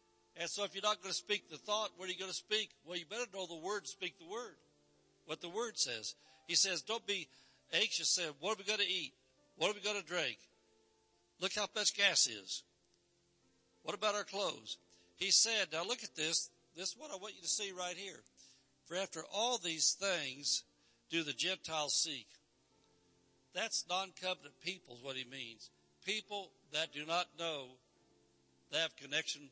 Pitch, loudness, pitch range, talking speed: 175 Hz, -37 LUFS, 135-200 Hz, 195 wpm